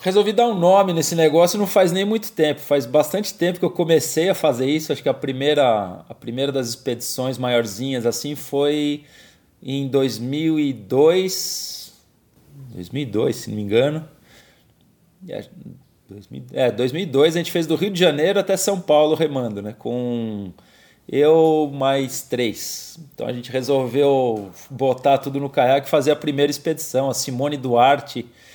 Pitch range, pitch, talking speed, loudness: 130-160 Hz, 145 Hz, 150 wpm, -20 LUFS